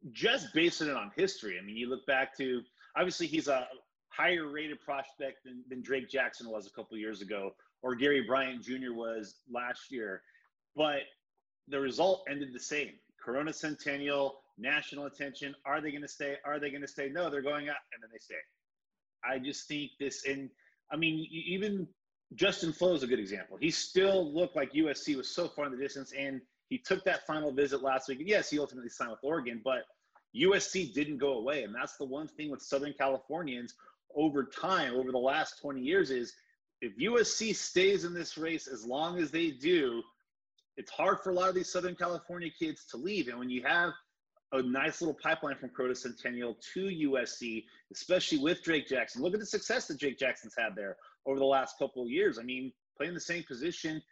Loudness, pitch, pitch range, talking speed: -34 LUFS, 145 Hz, 130-180 Hz, 205 wpm